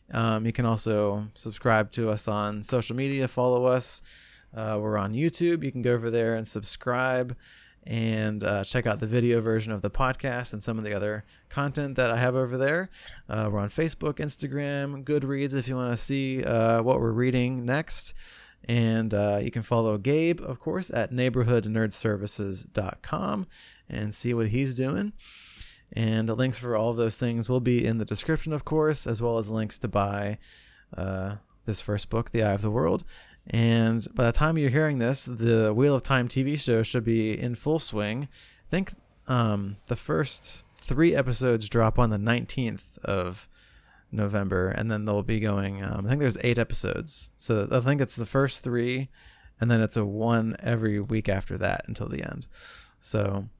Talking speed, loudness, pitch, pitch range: 185 wpm, -27 LUFS, 115 Hz, 105-130 Hz